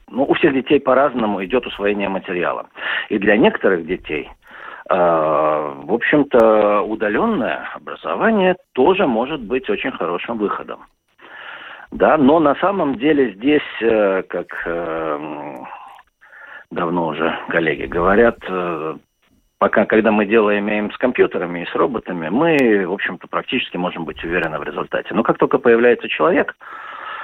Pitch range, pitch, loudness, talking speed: 95-140 Hz, 110 Hz, -17 LUFS, 135 wpm